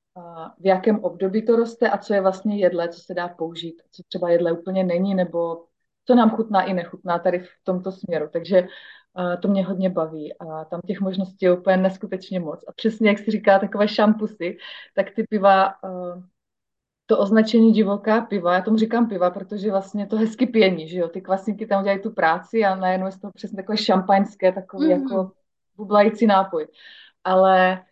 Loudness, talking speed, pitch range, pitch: -21 LUFS, 185 wpm, 180-210 Hz, 190 Hz